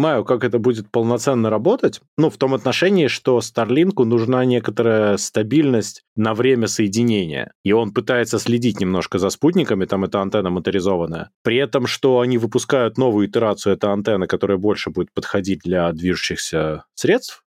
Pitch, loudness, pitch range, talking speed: 110 Hz, -19 LUFS, 100-125 Hz, 150 wpm